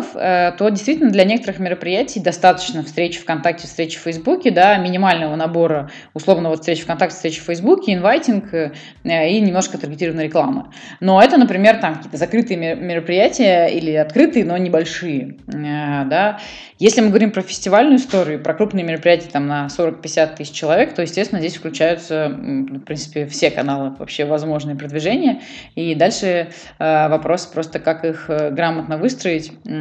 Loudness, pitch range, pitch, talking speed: -17 LUFS, 155-190 Hz, 170 Hz, 140 wpm